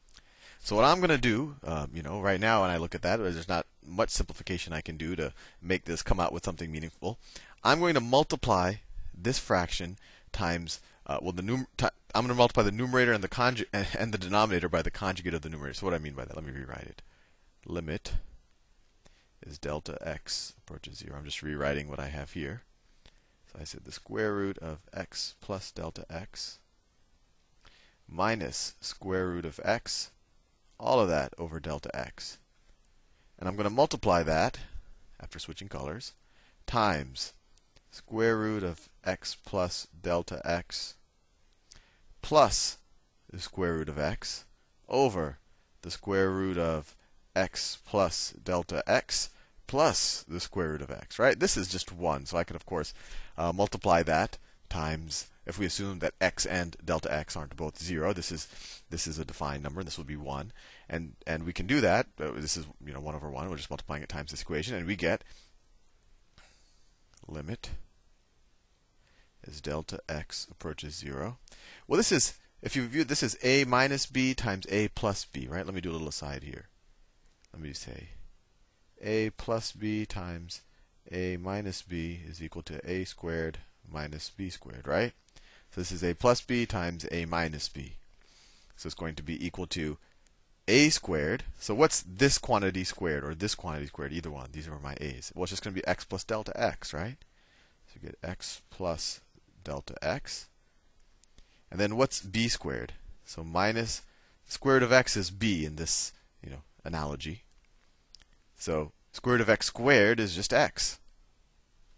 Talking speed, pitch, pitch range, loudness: 180 wpm, 85 Hz, 75-100 Hz, -31 LUFS